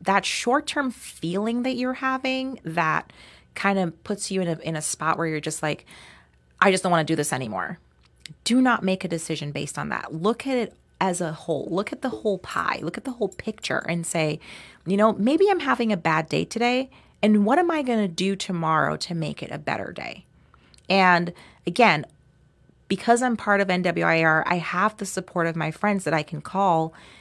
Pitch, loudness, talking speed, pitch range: 190 Hz, -24 LUFS, 210 wpm, 160-220 Hz